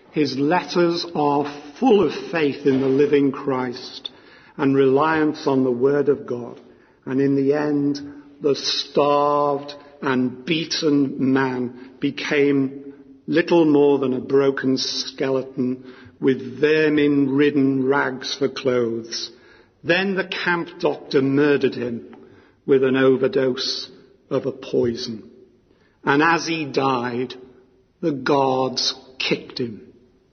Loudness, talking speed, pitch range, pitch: -20 LUFS, 115 wpm, 130-145 Hz, 140 Hz